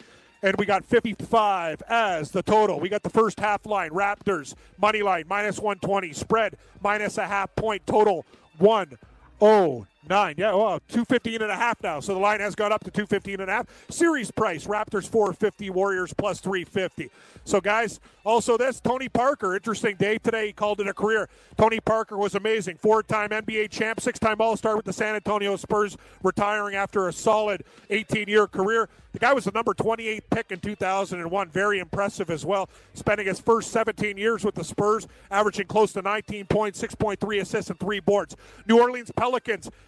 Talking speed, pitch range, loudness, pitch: 180 wpm, 195-220 Hz, -24 LUFS, 210 Hz